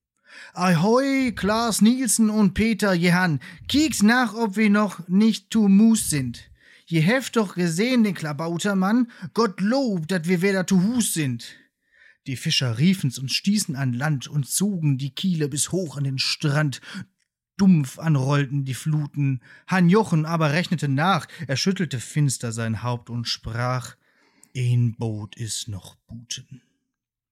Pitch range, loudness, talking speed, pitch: 135-205 Hz, -22 LUFS, 145 wpm, 165 Hz